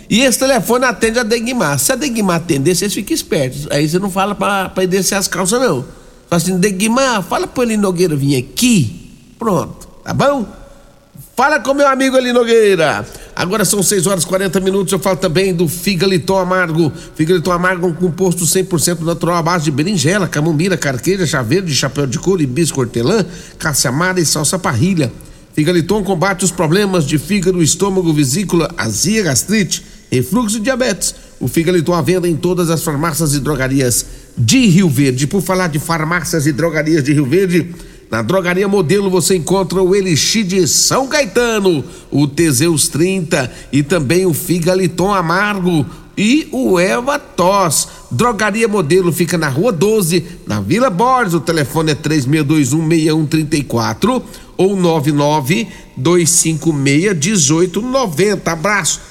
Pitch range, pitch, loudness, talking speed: 160-200 Hz, 180 Hz, -14 LUFS, 160 wpm